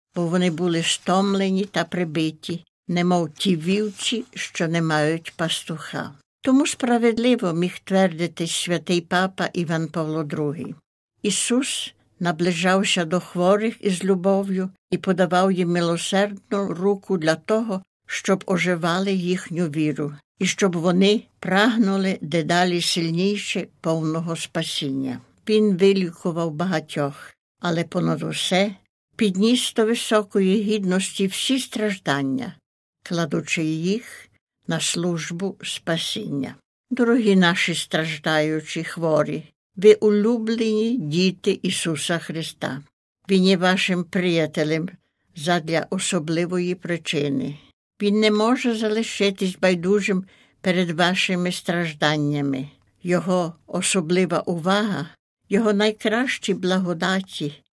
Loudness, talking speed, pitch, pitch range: -22 LUFS, 100 wpm, 180 Hz, 165-200 Hz